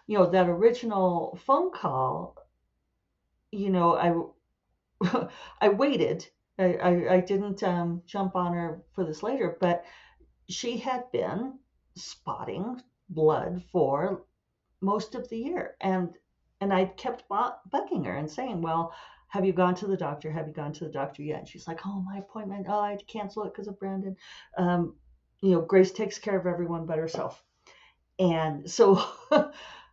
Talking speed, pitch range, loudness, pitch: 165 wpm, 170-210 Hz, -28 LUFS, 190 Hz